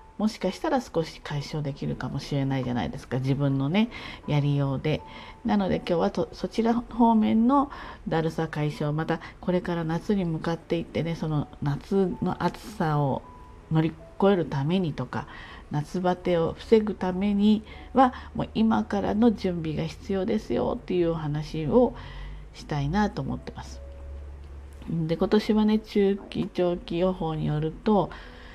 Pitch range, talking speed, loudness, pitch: 145-205 Hz, 295 characters per minute, -26 LUFS, 170 Hz